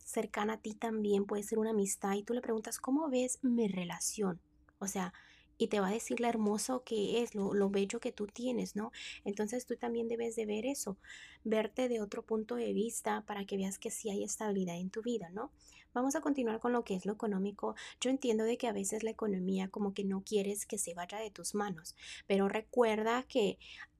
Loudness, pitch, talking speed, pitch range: -36 LUFS, 220 Hz, 225 wpm, 200-235 Hz